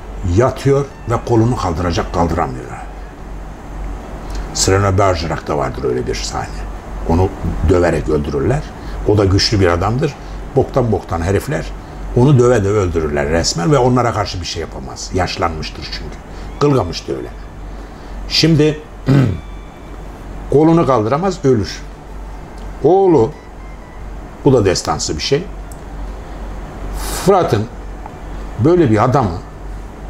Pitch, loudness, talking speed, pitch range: 90 Hz, -15 LUFS, 105 wpm, 75-115 Hz